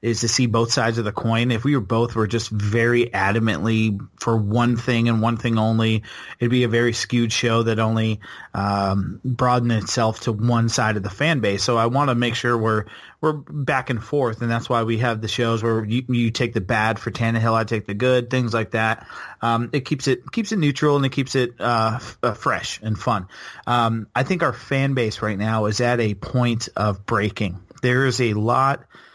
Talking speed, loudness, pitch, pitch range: 220 wpm, -21 LUFS, 115 Hz, 110-125 Hz